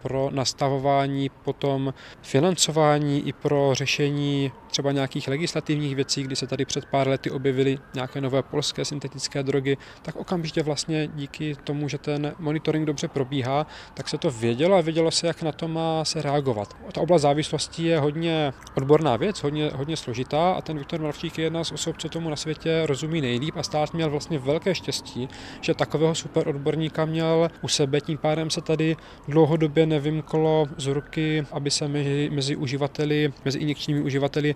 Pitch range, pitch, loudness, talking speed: 140-160 Hz, 150 Hz, -25 LUFS, 170 wpm